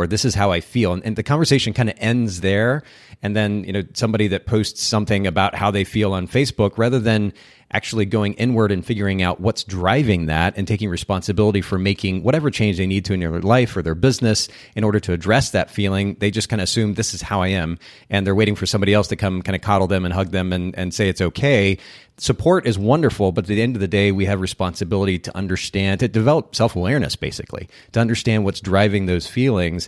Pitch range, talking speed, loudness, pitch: 95-110 Hz, 230 wpm, -19 LUFS, 100 Hz